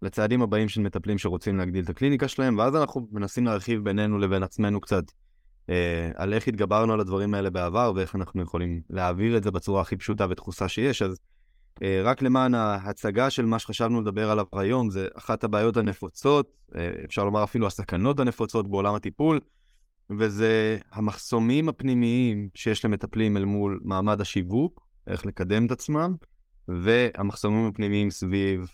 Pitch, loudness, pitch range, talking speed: 105 Hz, -26 LUFS, 95-115 Hz, 155 wpm